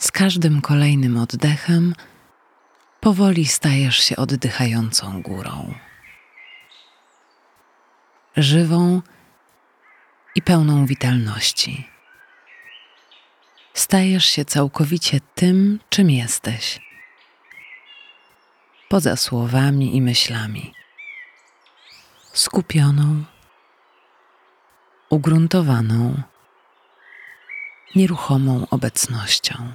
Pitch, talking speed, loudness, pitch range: 145 Hz, 55 wpm, -18 LUFS, 125-175 Hz